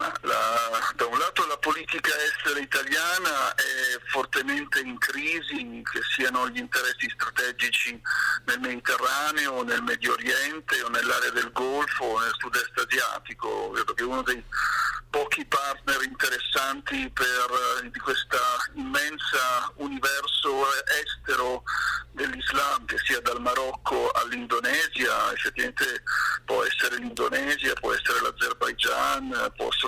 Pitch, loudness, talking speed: 325 Hz, -26 LUFS, 110 wpm